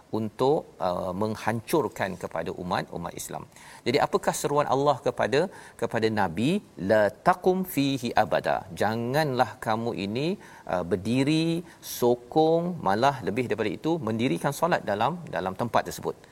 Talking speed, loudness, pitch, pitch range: 120 wpm, -27 LUFS, 130 Hz, 110-160 Hz